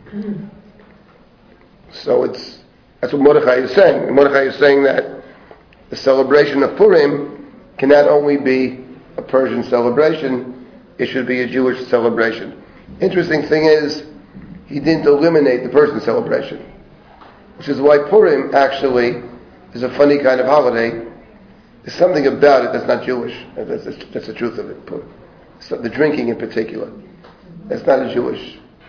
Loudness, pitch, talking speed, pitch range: -15 LUFS, 140 Hz, 145 wpm, 125-155 Hz